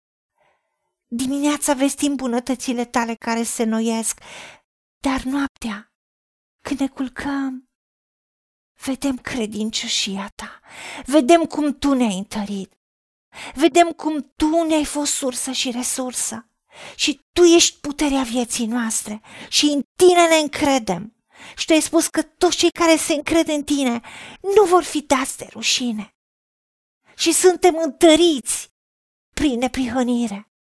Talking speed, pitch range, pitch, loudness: 120 wpm, 240-310 Hz, 275 Hz, -19 LUFS